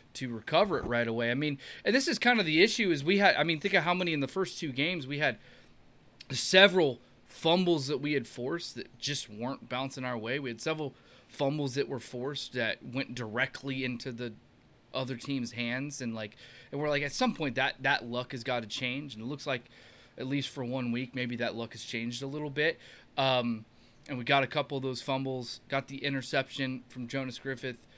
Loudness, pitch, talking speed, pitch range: -31 LUFS, 135 Hz, 225 wpm, 125-145 Hz